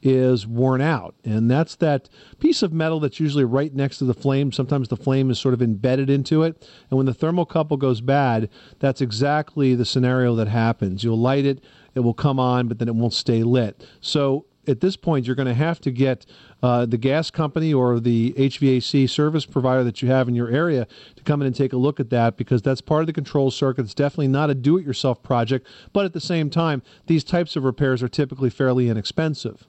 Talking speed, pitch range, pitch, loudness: 225 wpm, 125-150 Hz, 135 Hz, -21 LUFS